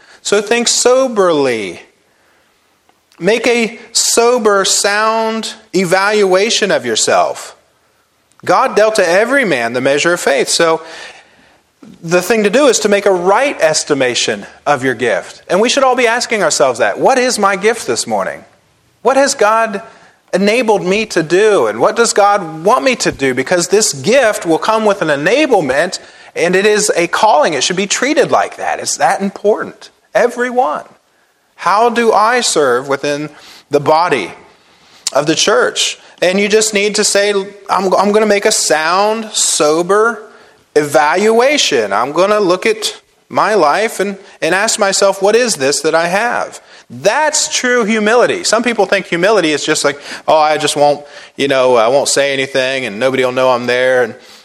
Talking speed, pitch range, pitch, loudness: 170 wpm, 160-225 Hz, 205 Hz, -12 LUFS